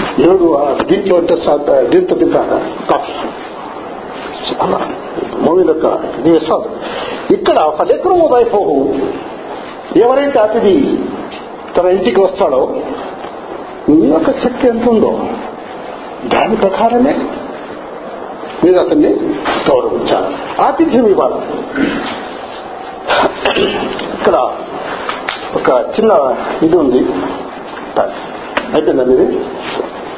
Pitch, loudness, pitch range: 275 Hz, -13 LUFS, 225-380 Hz